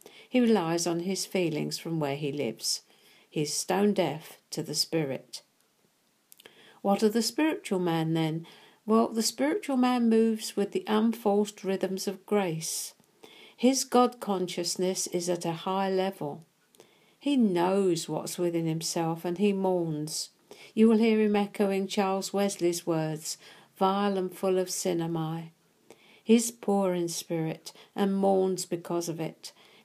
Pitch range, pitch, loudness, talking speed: 165-210 Hz, 190 Hz, -28 LUFS, 145 wpm